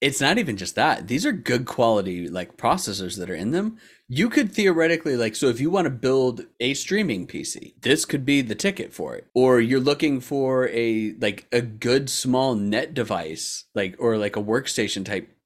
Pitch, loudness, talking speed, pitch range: 125 Hz, -23 LUFS, 200 wpm, 105-145 Hz